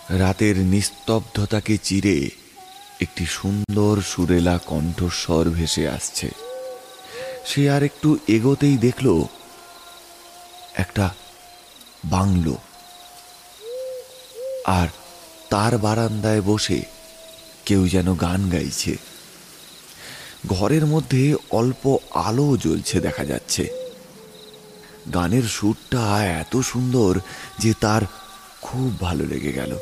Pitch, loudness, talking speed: 110 Hz, -21 LUFS, 85 wpm